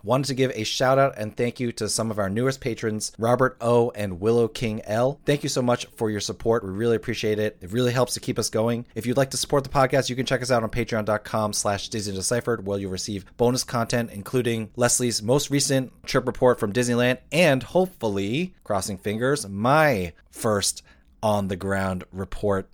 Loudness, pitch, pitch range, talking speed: -24 LUFS, 115 Hz, 105-130 Hz, 205 wpm